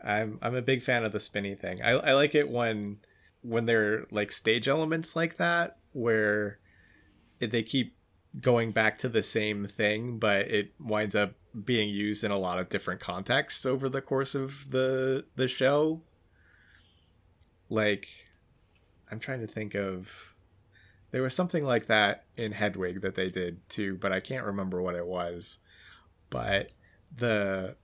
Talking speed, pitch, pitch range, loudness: 160 wpm, 105 Hz, 95-120 Hz, -29 LUFS